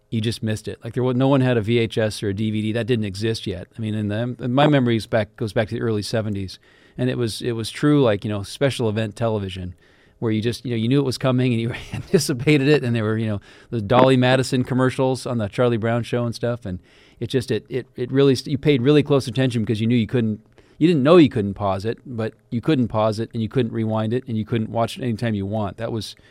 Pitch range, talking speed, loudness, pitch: 110-125 Hz, 275 wpm, -21 LUFS, 115 Hz